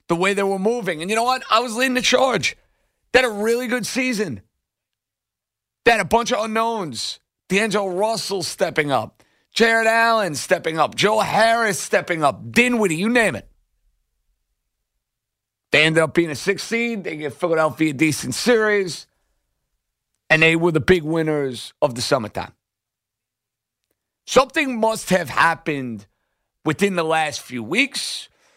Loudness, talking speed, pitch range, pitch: -19 LUFS, 155 wpm, 150-225 Hz, 185 Hz